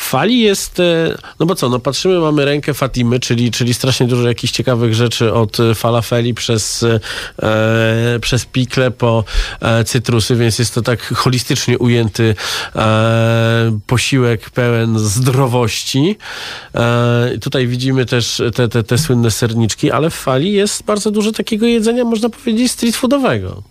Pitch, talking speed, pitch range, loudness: 125 Hz, 145 wpm, 115-140 Hz, -14 LUFS